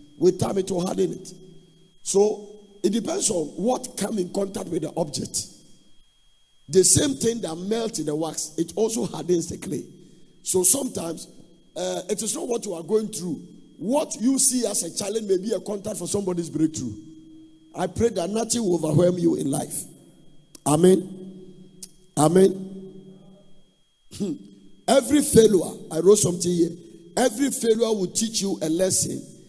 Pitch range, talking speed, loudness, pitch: 175-215 Hz, 160 wpm, -22 LUFS, 185 Hz